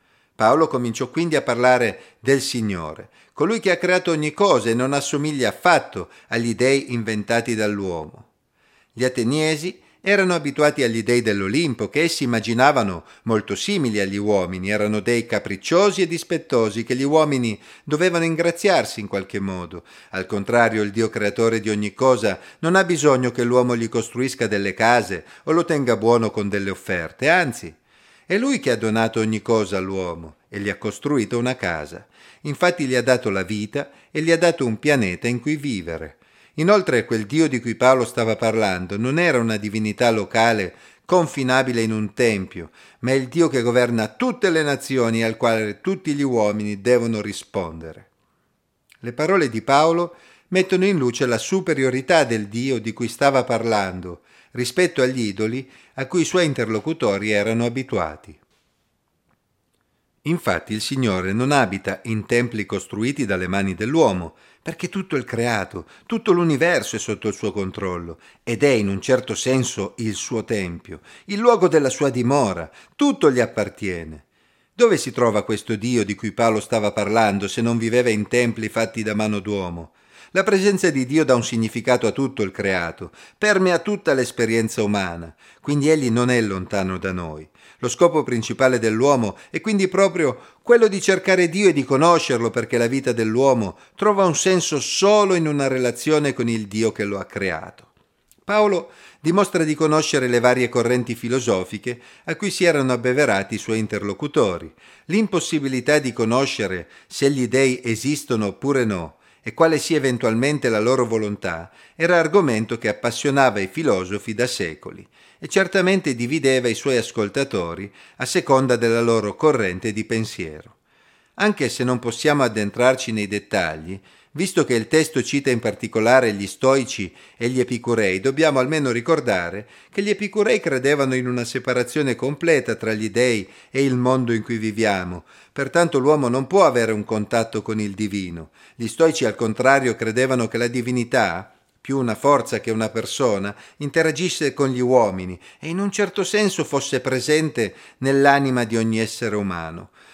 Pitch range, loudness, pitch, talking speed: 110-145 Hz, -20 LUFS, 120 Hz, 160 wpm